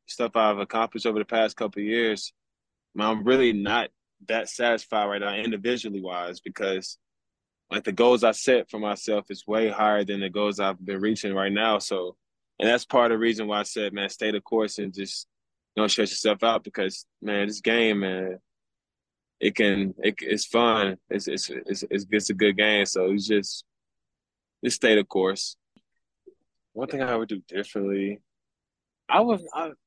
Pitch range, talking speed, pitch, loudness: 100-115 Hz, 190 wpm, 105 Hz, -25 LUFS